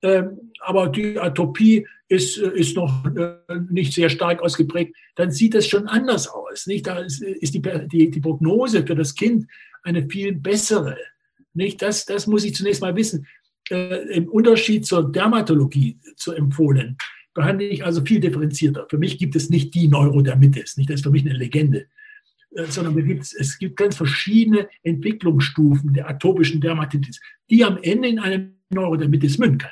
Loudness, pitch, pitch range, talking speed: -19 LUFS, 175 Hz, 155-205 Hz, 175 wpm